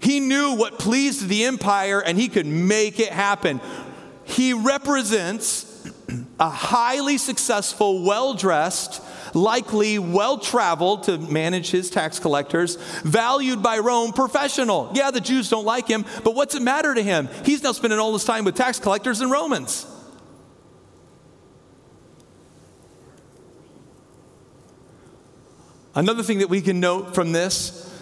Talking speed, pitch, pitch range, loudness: 135 wpm, 220 Hz, 190-255 Hz, -21 LUFS